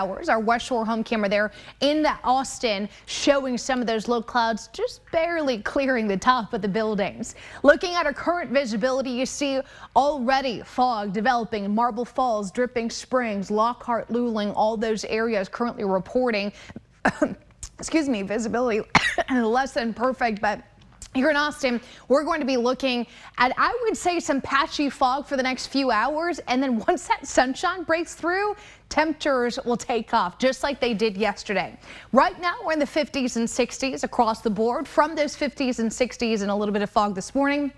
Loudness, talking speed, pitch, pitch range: -24 LUFS, 175 wpm, 250 Hz, 225-285 Hz